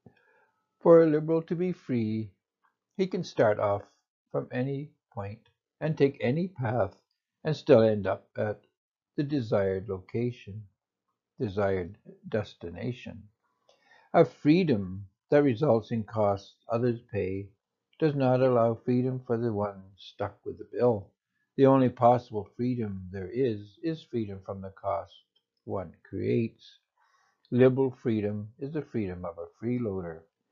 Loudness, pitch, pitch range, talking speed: -28 LUFS, 115 Hz, 100-135 Hz, 130 wpm